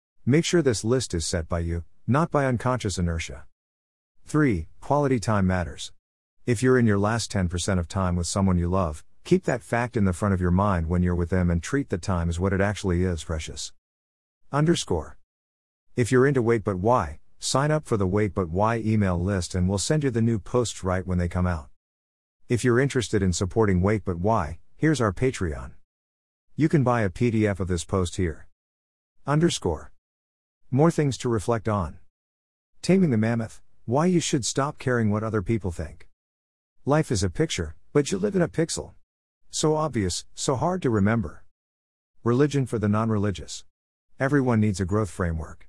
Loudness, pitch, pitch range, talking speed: -25 LUFS, 100 Hz, 85-120 Hz, 185 wpm